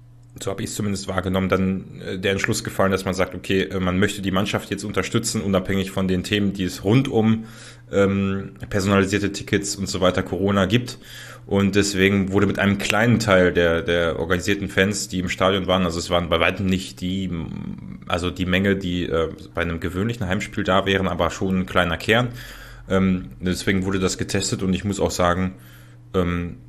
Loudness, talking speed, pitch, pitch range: -21 LUFS, 190 wpm, 95 Hz, 90-100 Hz